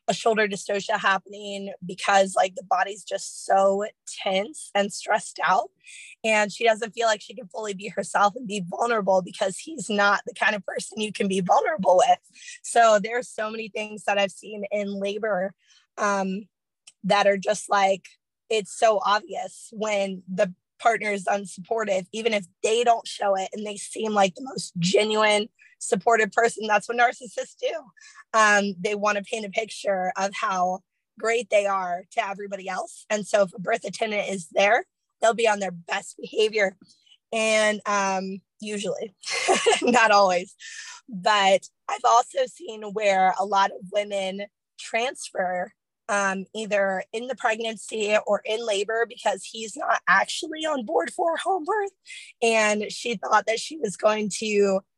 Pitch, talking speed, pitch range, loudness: 210 Hz, 165 wpm, 195-225 Hz, -24 LUFS